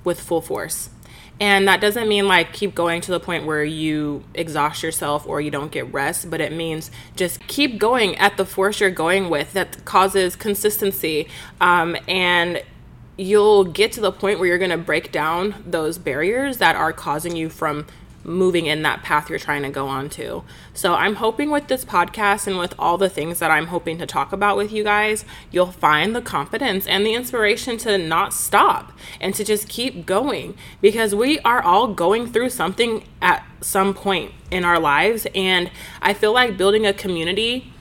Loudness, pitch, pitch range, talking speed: -19 LUFS, 185 Hz, 165-210 Hz, 190 wpm